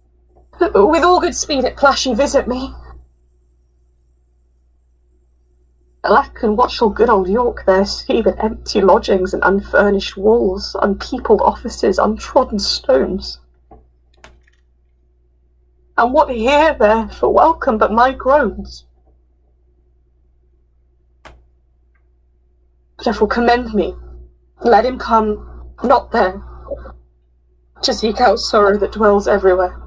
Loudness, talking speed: -15 LUFS, 100 wpm